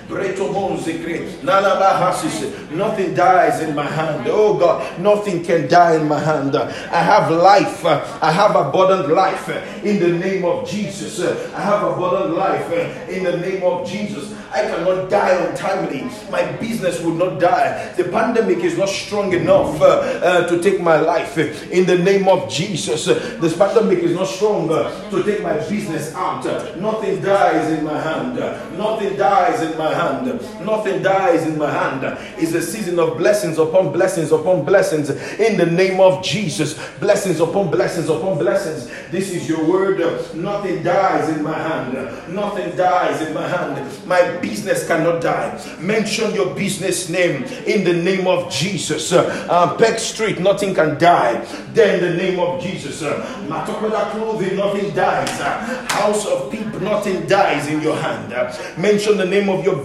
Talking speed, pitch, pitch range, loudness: 165 wpm, 185 Hz, 170-200 Hz, -18 LUFS